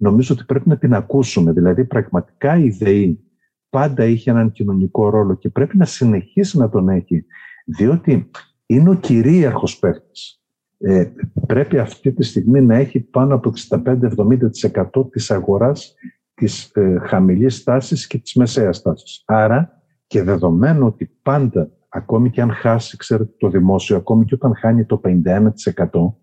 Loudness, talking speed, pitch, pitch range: -16 LUFS, 150 wpm, 115 Hz, 100-135 Hz